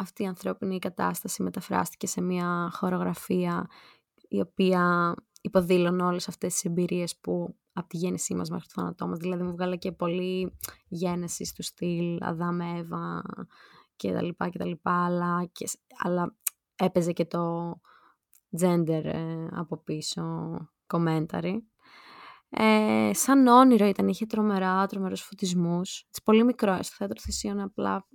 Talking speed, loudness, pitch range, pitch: 140 wpm, -28 LUFS, 170-190 Hz, 180 Hz